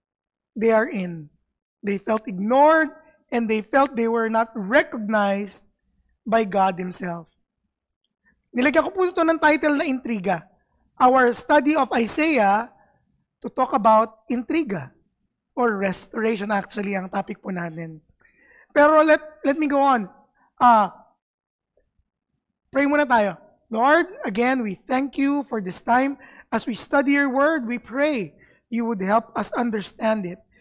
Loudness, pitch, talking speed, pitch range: -21 LUFS, 235 Hz, 130 wpm, 205-280 Hz